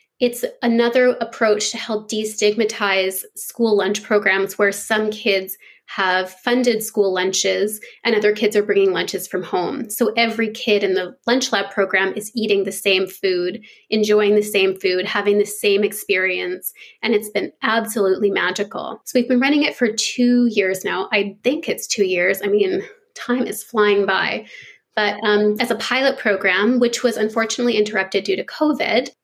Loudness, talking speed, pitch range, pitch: -19 LUFS, 170 wpm, 195-230 Hz, 210 Hz